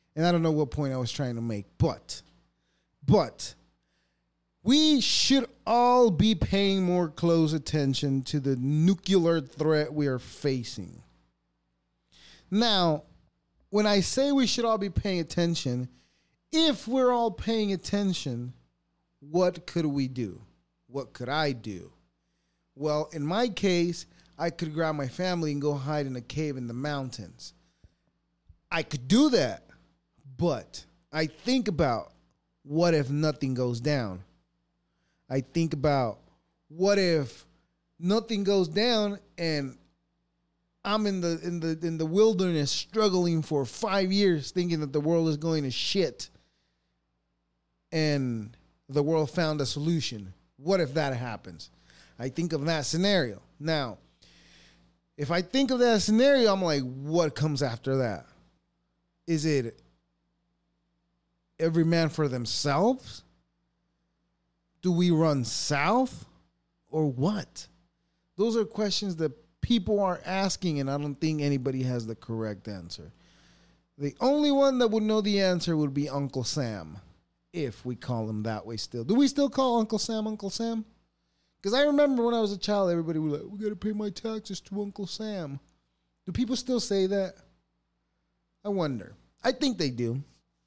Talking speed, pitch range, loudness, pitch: 150 wpm, 130-195 Hz, -27 LUFS, 160 Hz